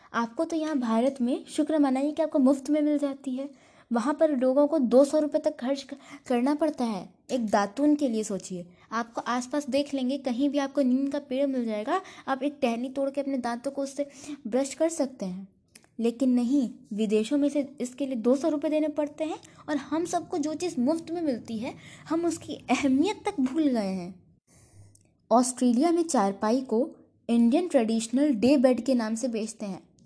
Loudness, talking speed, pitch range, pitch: -27 LUFS, 200 wpm, 235-295 Hz, 275 Hz